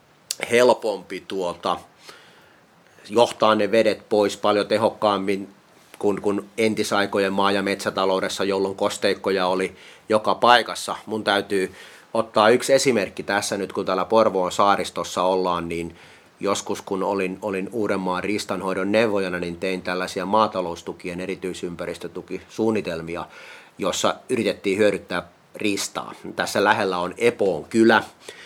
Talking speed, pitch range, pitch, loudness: 110 wpm, 95-110 Hz, 100 Hz, -22 LUFS